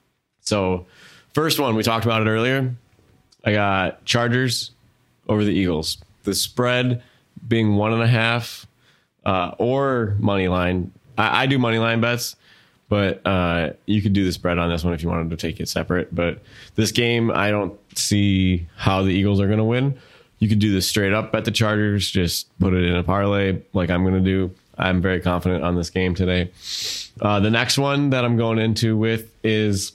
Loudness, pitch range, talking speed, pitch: -21 LUFS, 95-115 Hz, 195 wpm, 105 Hz